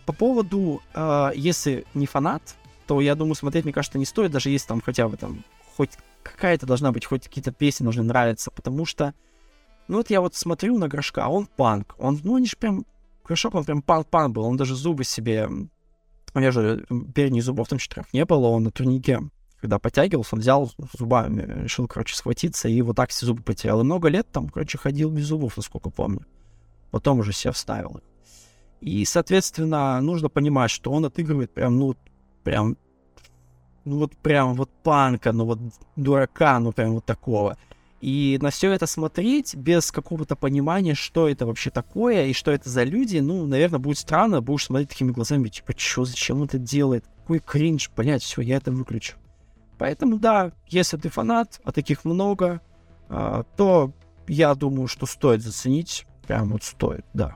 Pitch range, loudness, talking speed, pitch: 115-160 Hz, -23 LUFS, 180 wpm, 135 Hz